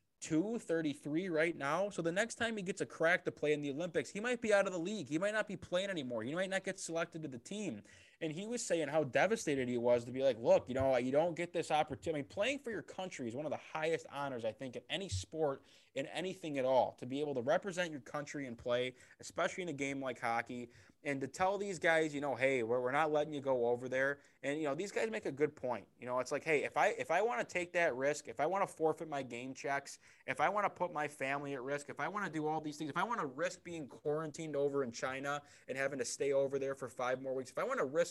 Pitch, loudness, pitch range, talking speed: 150 Hz, -37 LUFS, 135-175 Hz, 285 wpm